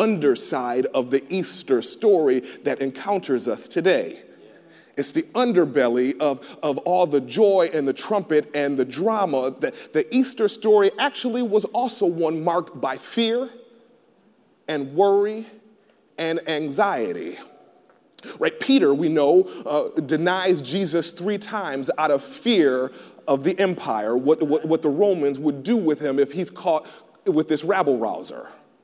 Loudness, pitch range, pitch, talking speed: -22 LUFS, 145-215 Hz, 180 Hz, 145 wpm